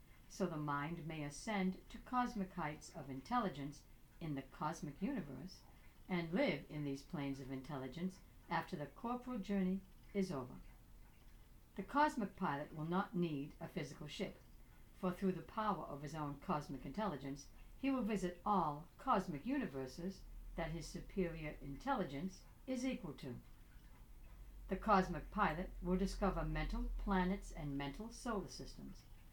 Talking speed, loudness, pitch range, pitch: 140 wpm, -43 LUFS, 145-195 Hz, 175 Hz